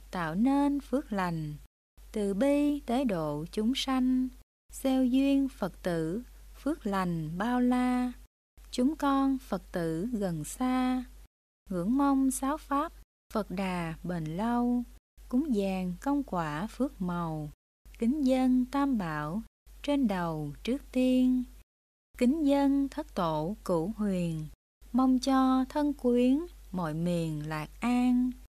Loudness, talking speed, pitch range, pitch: -30 LUFS, 125 wpm, 180-265 Hz, 245 Hz